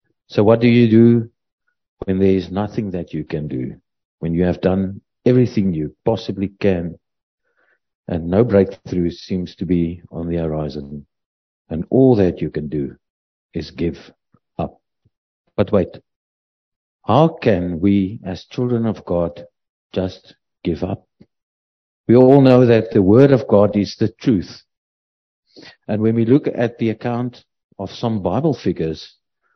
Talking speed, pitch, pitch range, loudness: 150 wpm, 100 Hz, 85-115 Hz, -18 LUFS